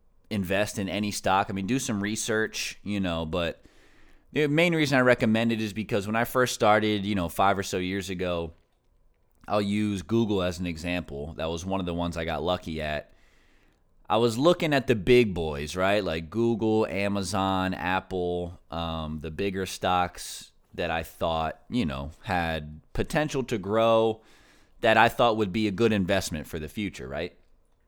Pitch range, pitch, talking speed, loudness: 85-110 Hz, 95 Hz, 180 wpm, -27 LUFS